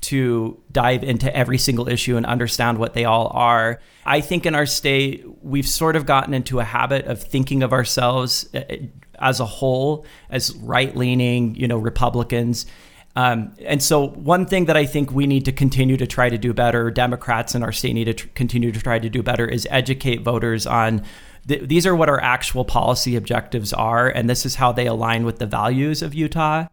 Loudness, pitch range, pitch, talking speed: -19 LUFS, 120-135 Hz, 125 Hz, 200 wpm